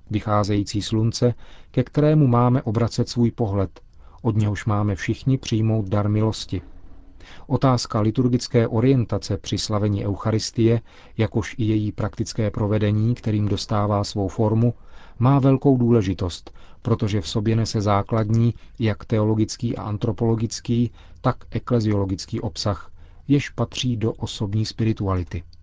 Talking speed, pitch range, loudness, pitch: 115 wpm, 100-120 Hz, -22 LUFS, 110 Hz